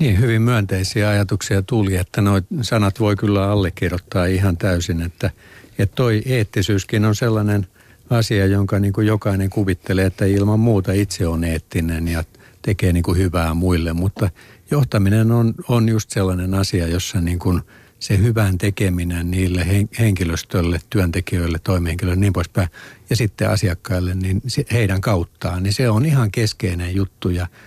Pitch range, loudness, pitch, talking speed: 90-110 Hz, -19 LUFS, 100 Hz, 150 wpm